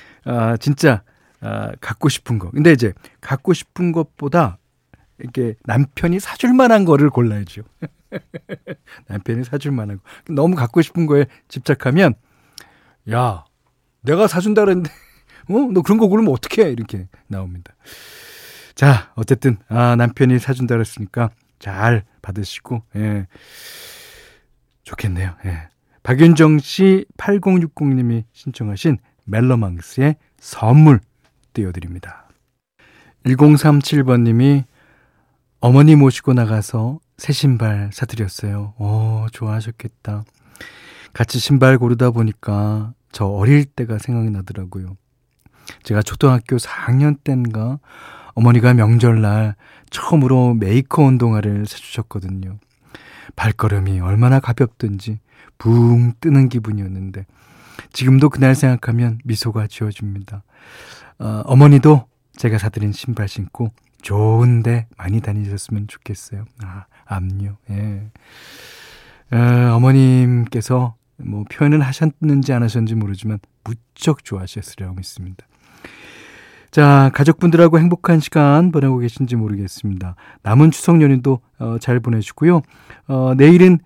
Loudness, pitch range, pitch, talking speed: -15 LUFS, 105-140 Hz, 120 Hz, 265 characters per minute